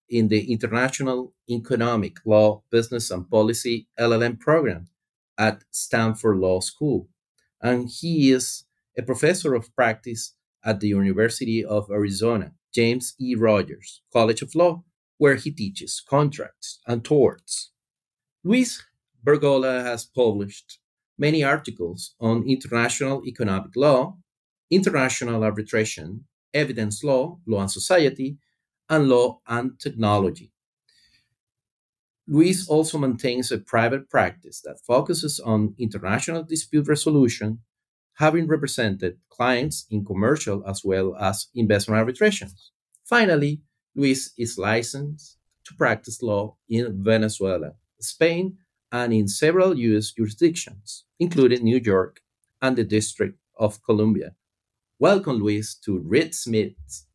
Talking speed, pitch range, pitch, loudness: 115 wpm, 105-140 Hz, 120 Hz, -23 LUFS